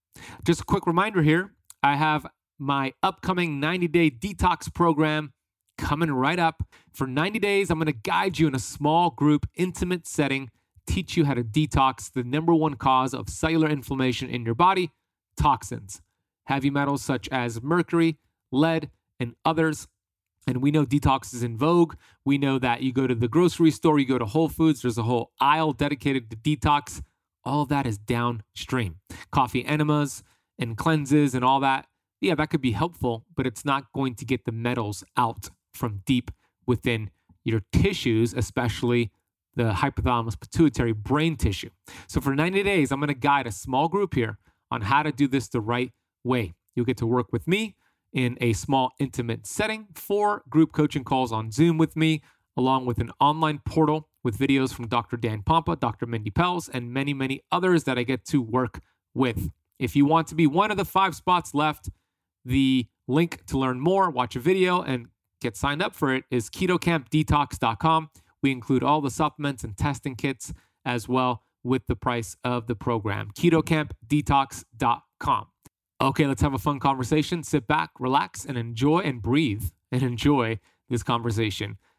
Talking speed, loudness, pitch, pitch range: 180 wpm, -25 LUFS, 135 Hz, 120-155 Hz